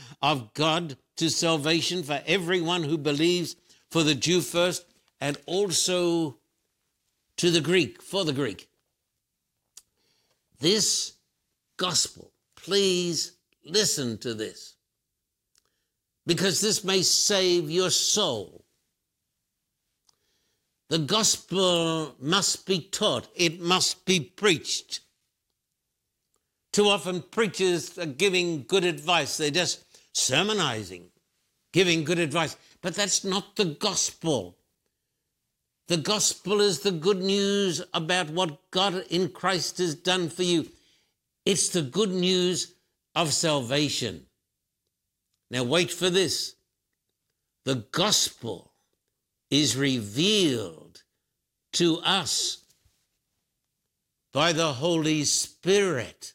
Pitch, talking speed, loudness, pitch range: 175 Hz, 100 wpm, -25 LUFS, 155-185 Hz